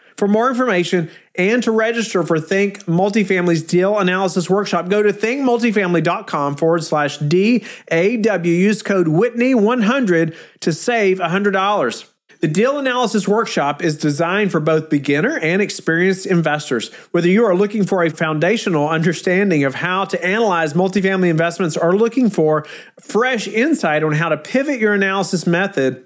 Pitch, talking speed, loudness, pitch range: 185 Hz, 145 wpm, -17 LUFS, 165-210 Hz